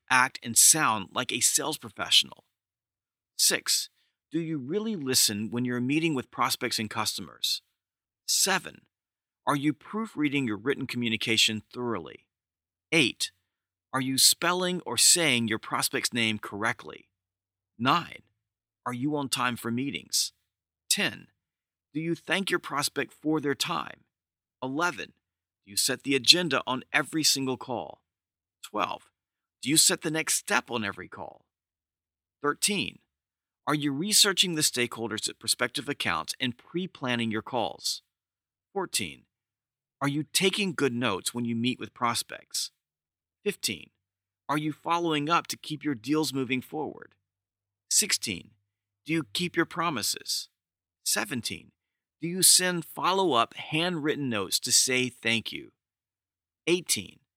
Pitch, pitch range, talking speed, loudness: 125 Hz, 105-155 Hz, 135 wpm, -26 LUFS